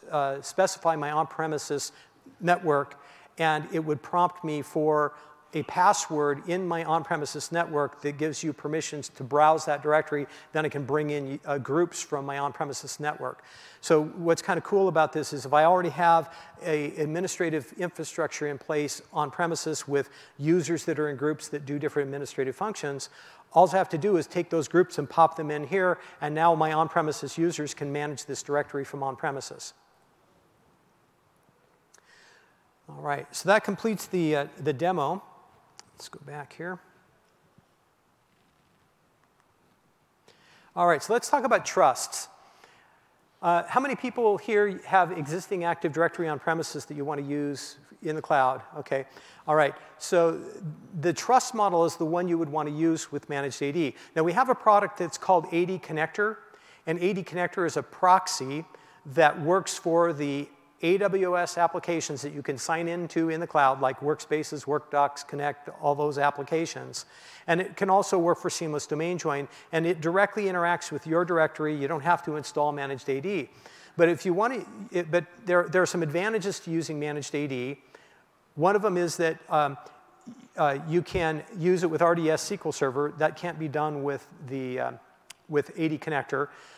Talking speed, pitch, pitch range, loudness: 175 wpm, 160 Hz, 145-175 Hz, -27 LUFS